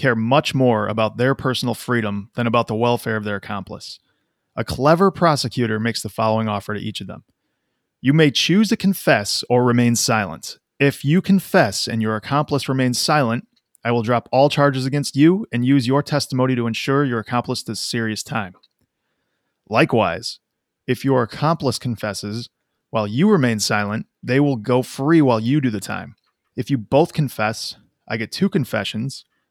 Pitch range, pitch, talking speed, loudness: 110-140 Hz, 125 Hz, 175 wpm, -19 LUFS